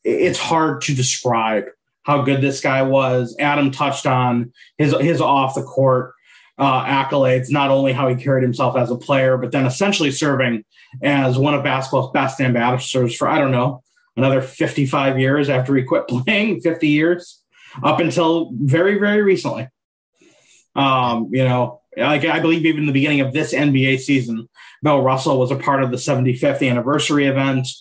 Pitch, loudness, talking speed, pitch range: 135 Hz, -17 LUFS, 175 wpm, 130-145 Hz